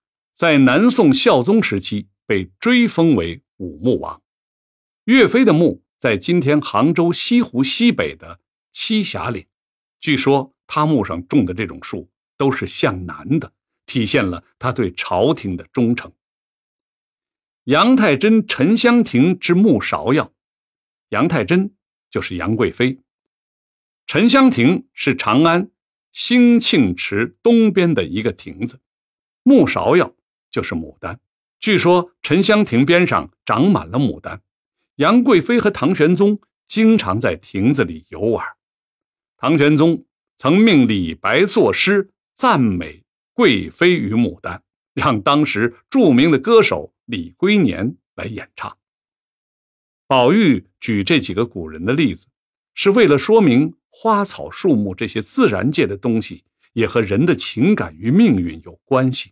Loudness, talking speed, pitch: -16 LUFS, 195 characters per minute, 180 Hz